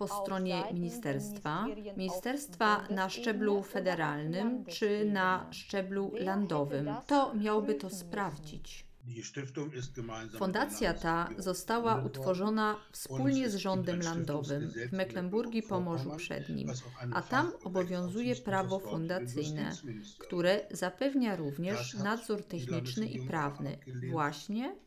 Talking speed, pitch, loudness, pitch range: 95 wpm, 185 Hz, -34 LUFS, 150-210 Hz